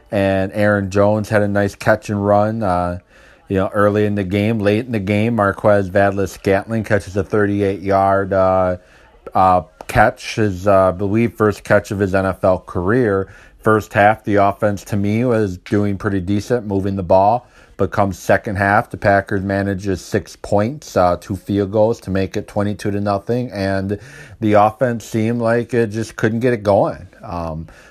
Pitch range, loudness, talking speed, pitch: 95-110 Hz, -17 LUFS, 180 wpm, 100 Hz